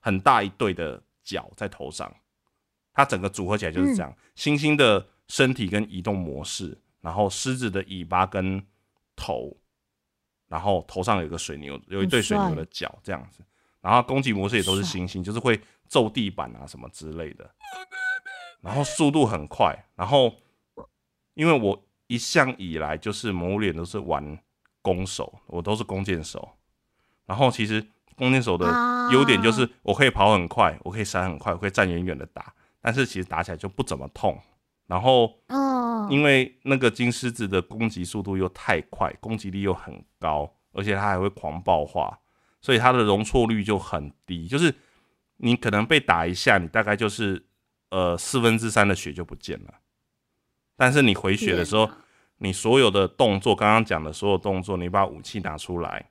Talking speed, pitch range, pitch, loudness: 265 characters per minute, 90-120 Hz, 100 Hz, -24 LUFS